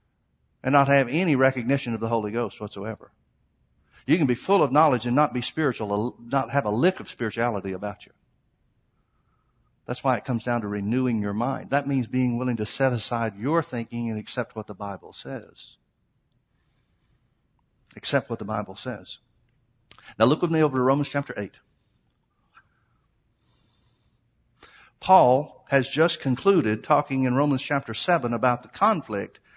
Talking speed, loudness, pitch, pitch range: 160 wpm, -24 LUFS, 125 Hz, 110-140 Hz